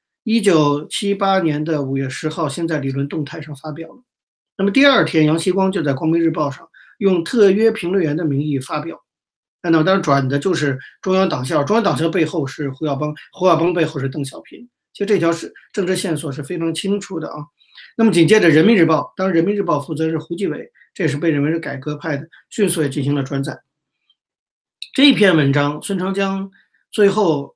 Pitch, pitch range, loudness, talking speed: 165 Hz, 150-195 Hz, -18 LUFS, 305 characters per minute